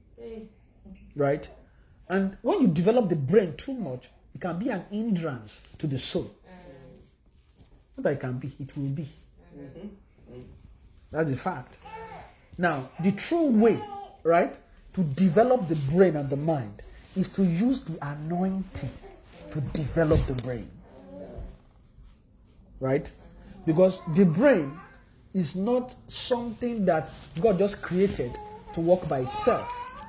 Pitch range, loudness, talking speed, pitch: 140-205 Hz, -27 LUFS, 130 wpm, 175 Hz